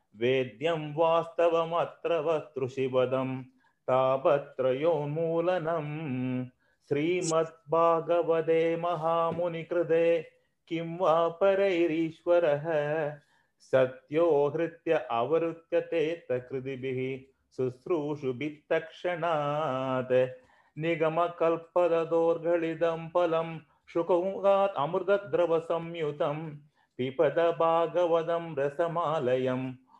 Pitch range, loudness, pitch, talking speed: 140-170 Hz, -29 LUFS, 165 Hz, 45 wpm